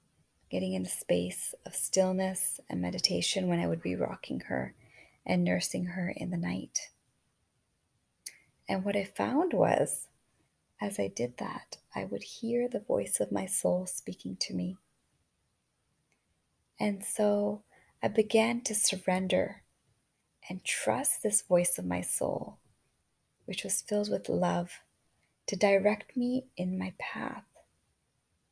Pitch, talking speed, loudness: 180 Hz, 135 wpm, -30 LUFS